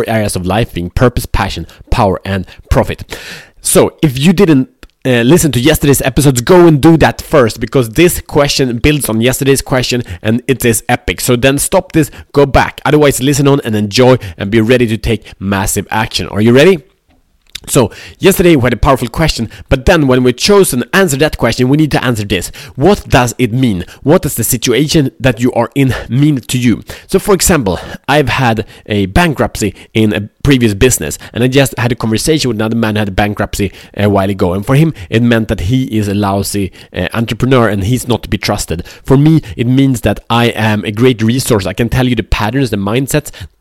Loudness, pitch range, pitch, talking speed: -11 LUFS, 105-140 Hz, 120 Hz, 210 wpm